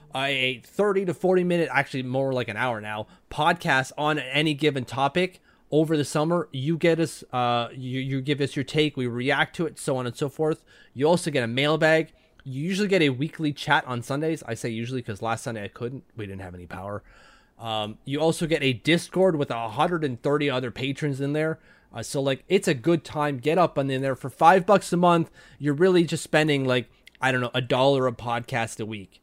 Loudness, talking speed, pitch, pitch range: -24 LUFS, 220 wpm, 140 Hz, 125-160 Hz